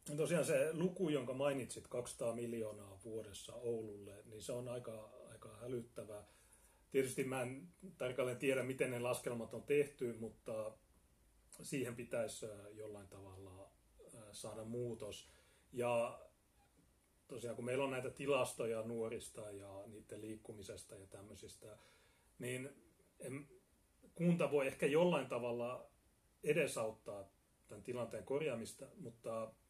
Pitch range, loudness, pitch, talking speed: 110-130 Hz, -42 LUFS, 115 Hz, 115 wpm